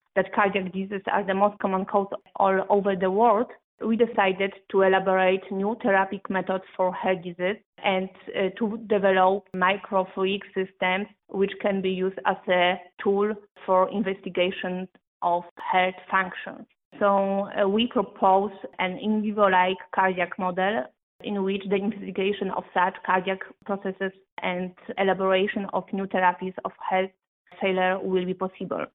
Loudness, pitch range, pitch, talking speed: -25 LUFS, 185-200 Hz, 190 Hz, 135 wpm